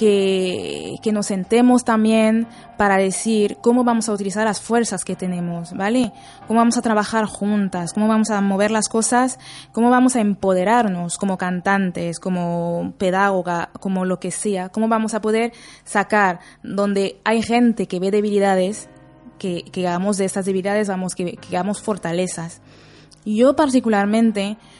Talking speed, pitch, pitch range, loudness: 155 wpm, 205 Hz, 185-225 Hz, -19 LUFS